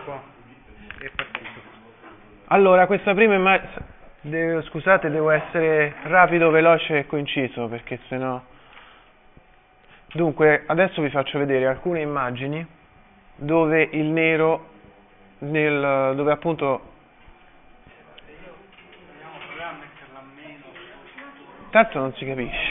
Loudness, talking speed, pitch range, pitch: -20 LUFS, 80 wpm, 140-165 Hz, 155 Hz